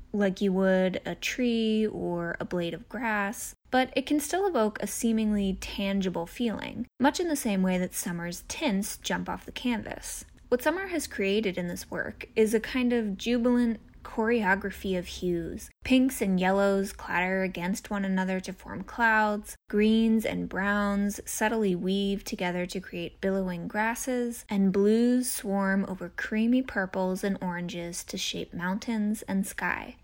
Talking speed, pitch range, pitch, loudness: 160 wpm, 190-230 Hz, 205 Hz, -28 LUFS